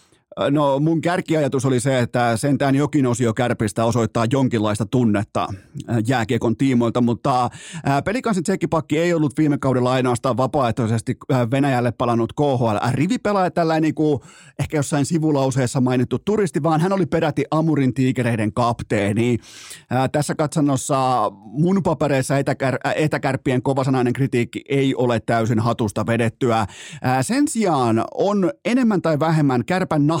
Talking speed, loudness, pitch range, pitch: 125 wpm, -20 LUFS, 120-155 Hz, 135 Hz